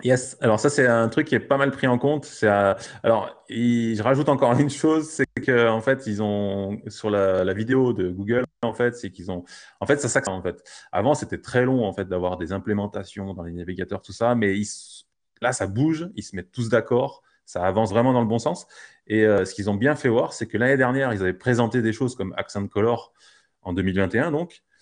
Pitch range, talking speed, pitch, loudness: 100-130 Hz, 235 wpm, 115 Hz, -23 LUFS